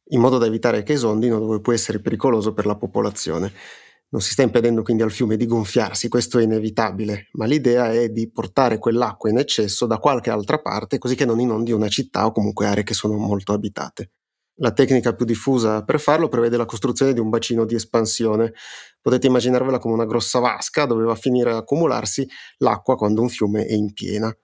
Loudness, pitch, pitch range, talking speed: -20 LUFS, 115 Hz, 110-125 Hz, 205 wpm